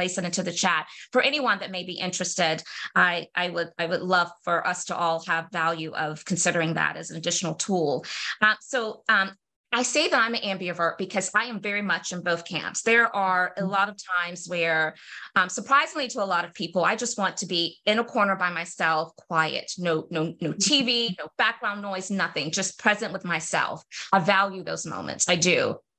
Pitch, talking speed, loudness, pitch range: 185 Hz, 205 wpm, -25 LUFS, 170-205 Hz